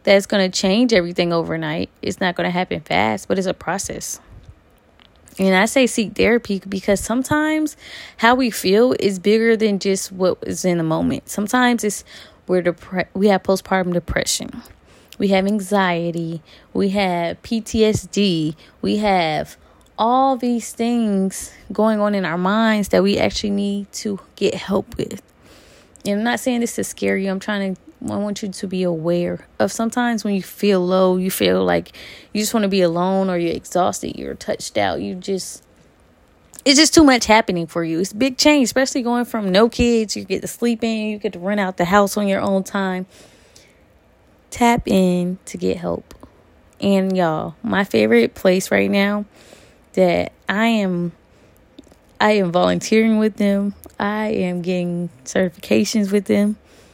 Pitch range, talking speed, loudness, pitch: 180-220 Hz, 175 wpm, -19 LUFS, 200 Hz